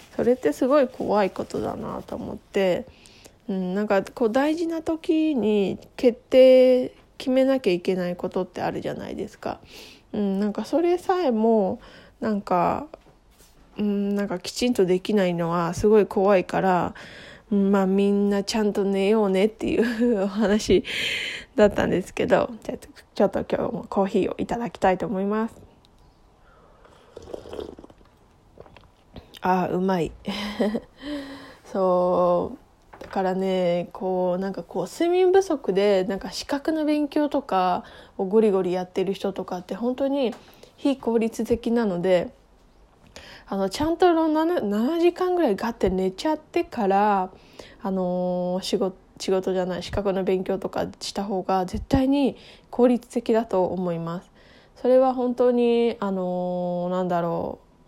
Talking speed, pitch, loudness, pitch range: 275 characters per minute, 205 Hz, -23 LUFS, 190-255 Hz